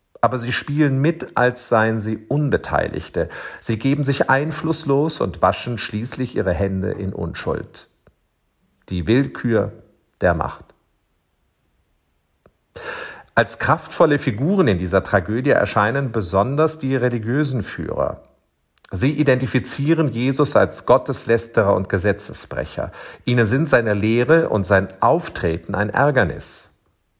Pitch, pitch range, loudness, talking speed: 120 Hz, 100-135 Hz, -19 LUFS, 110 wpm